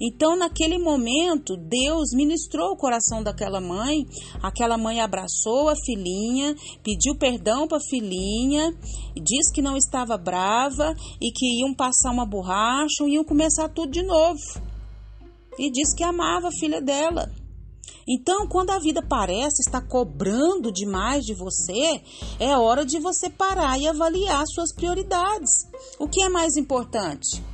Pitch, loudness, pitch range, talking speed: 285 Hz, -23 LUFS, 235-325 Hz, 150 wpm